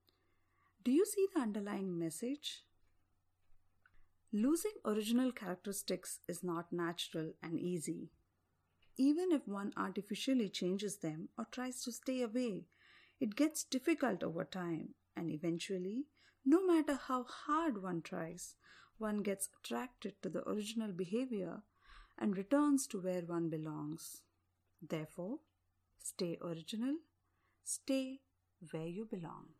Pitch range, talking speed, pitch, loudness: 165-255 Hz, 120 wpm, 195 Hz, -39 LUFS